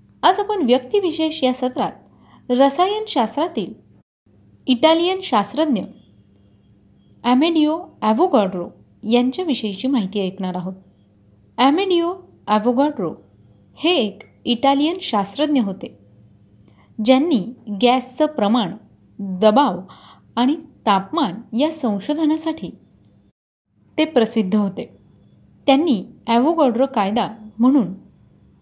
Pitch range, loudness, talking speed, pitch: 205-300 Hz, -19 LUFS, 75 wpm, 245 Hz